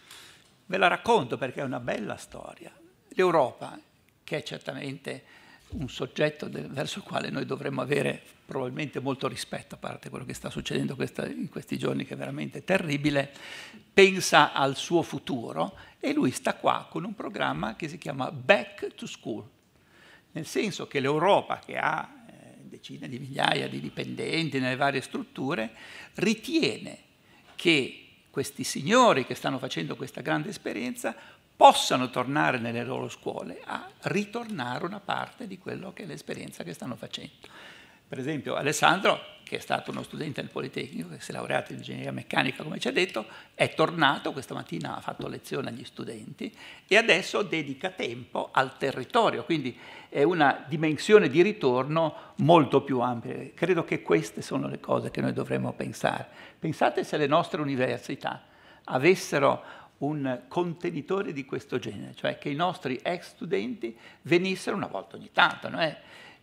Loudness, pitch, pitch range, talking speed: -28 LUFS, 140 Hz, 125-175 Hz, 155 wpm